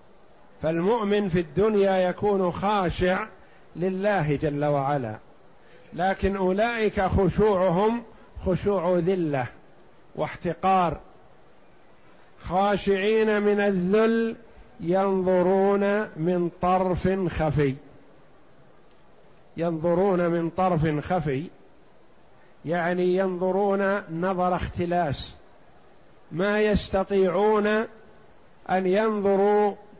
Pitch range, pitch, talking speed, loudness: 175-205 Hz, 185 Hz, 65 wpm, -24 LUFS